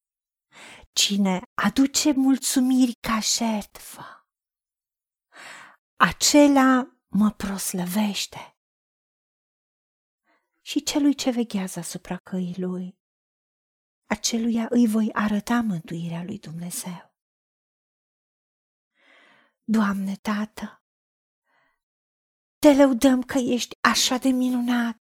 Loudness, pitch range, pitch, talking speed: -22 LUFS, 195-255 Hz, 220 Hz, 75 wpm